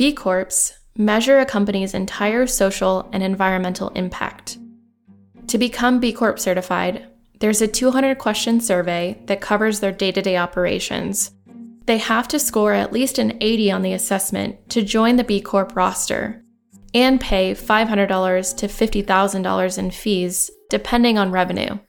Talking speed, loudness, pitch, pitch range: 150 wpm, -19 LUFS, 210 Hz, 190-235 Hz